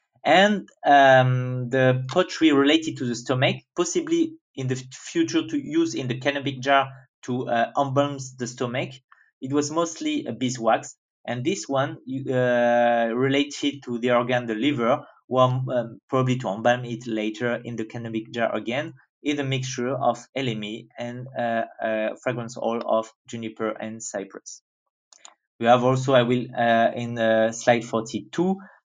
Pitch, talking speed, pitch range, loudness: 125 Hz, 155 wpm, 120-140 Hz, -23 LUFS